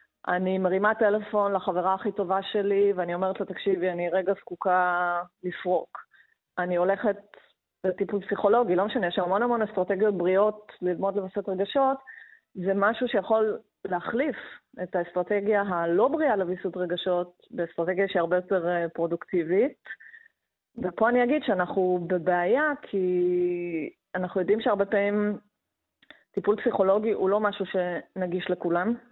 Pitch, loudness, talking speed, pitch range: 195 Hz, -26 LUFS, 125 wpm, 180-210 Hz